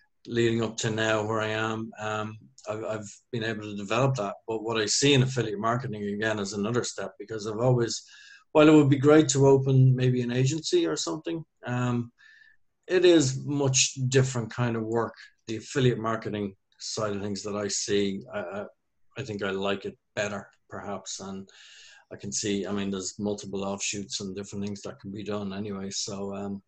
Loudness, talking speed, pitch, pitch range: -27 LUFS, 195 wpm, 110 Hz, 100-130 Hz